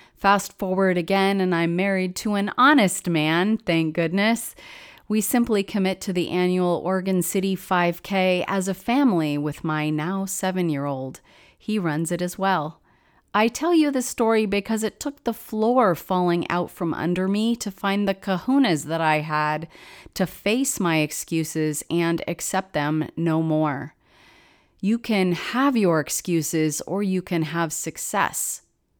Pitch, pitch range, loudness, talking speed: 185 Hz, 165-210 Hz, -23 LUFS, 155 wpm